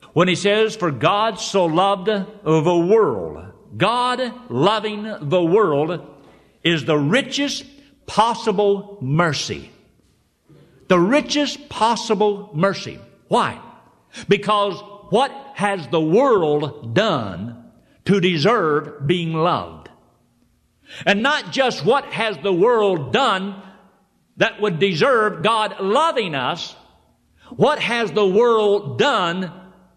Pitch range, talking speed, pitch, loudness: 175-220 Hz, 105 wpm, 200 Hz, -19 LUFS